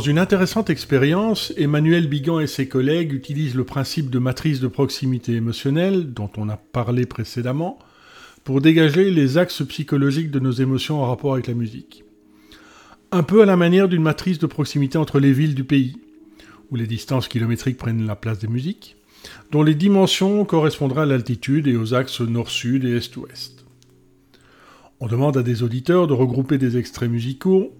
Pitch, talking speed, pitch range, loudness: 135 Hz, 170 wpm, 125-160 Hz, -20 LUFS